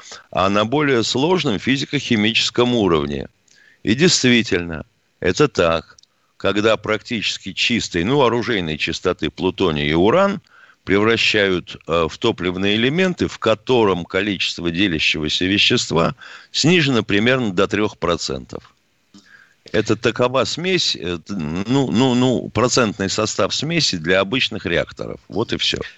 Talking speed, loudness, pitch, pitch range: 115 wpm, -18 LUFS, 105 Hz, 90-125 Hz